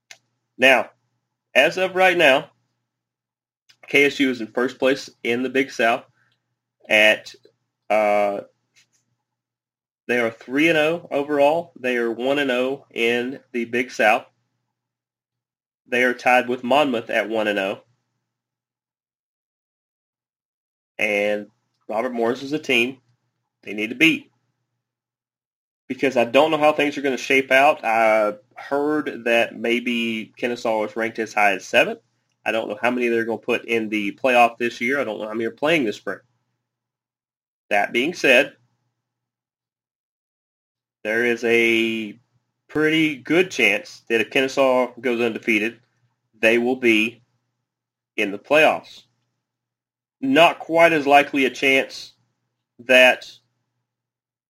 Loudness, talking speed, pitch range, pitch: -19 LUFS, 135 wpm, 115-135 Hz, 120 Hz